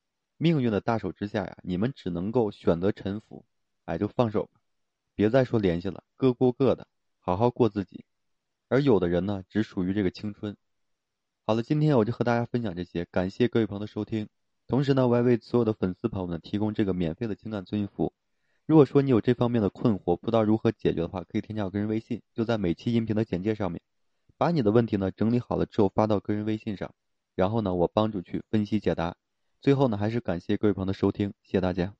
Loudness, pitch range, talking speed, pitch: -27 LUFS, 95-115 Hz, 350 characters per minute, 105 Hz